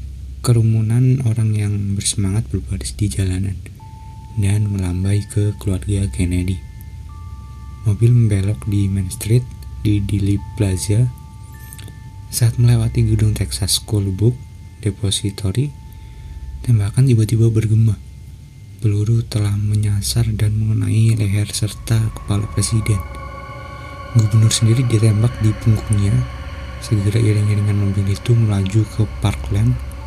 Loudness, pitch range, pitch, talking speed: -18 LUFS, 100-110 Hz, 105 Hz, 100 wpm